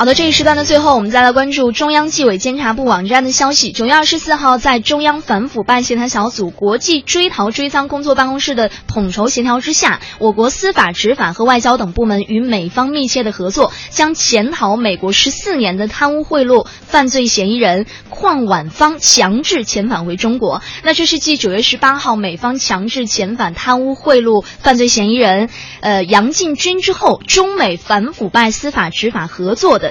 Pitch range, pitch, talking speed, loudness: 215-285 Hz, 245 Hz, 305 characters per minute, -12 LUFS